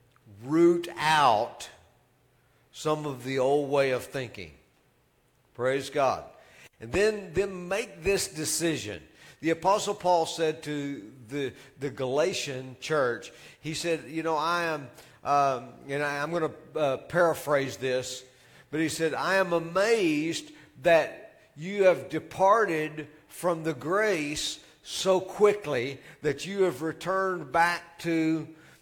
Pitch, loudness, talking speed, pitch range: 155 Hz, -28 LUFS, 130 wpm, 135-170 Hz